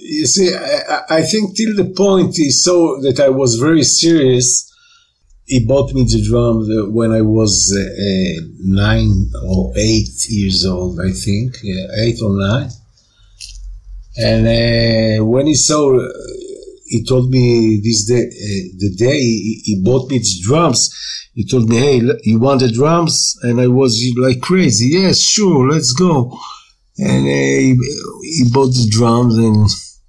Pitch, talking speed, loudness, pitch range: 120 Hz, 155 wpm, -13 LUFS, 110-145 Hz